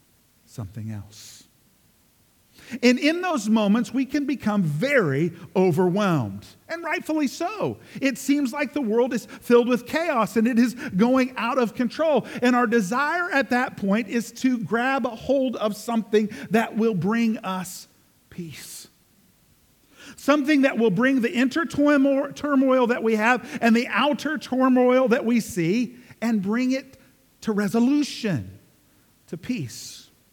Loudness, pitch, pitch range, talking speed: -22 LUFS, 235 Hz, 205-270 Hz, 140 wpm